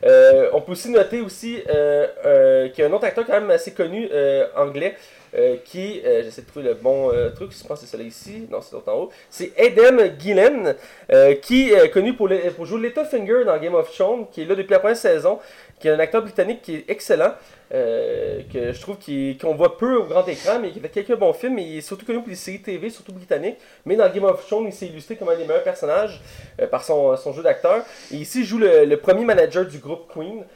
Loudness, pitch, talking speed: -19 LUFS, 235 Hz, 255 wpm